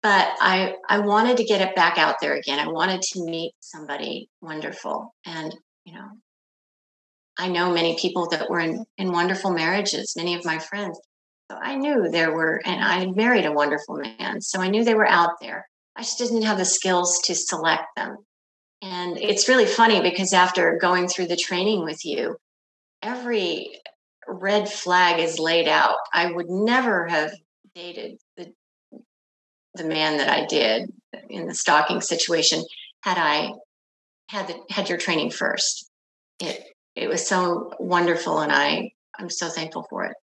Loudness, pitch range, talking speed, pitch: -22 LUFS, 170-210 Hz, 170 wpm, 180 Hz